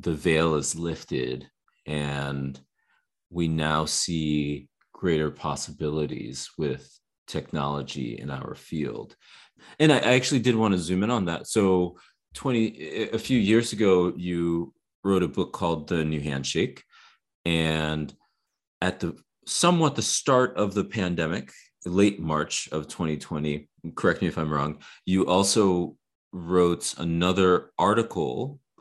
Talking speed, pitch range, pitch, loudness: 130 wpm, 75-95 Hz, 85 Hz, -26 LUFS